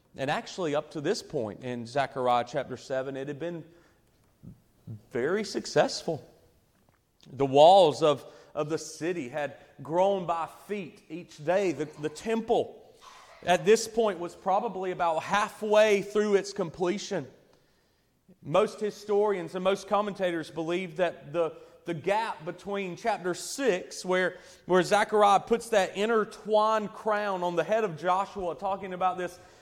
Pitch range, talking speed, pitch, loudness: 165-205 Hz, 140 wpm, 180 Hz, -28 LUFS